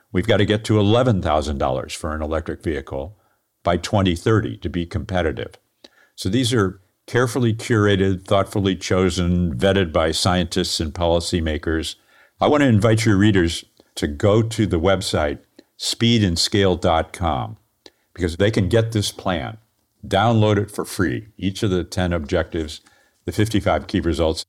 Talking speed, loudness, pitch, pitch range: 140 wpm, -20 LUFS, 95 Hz, 85-110 Hz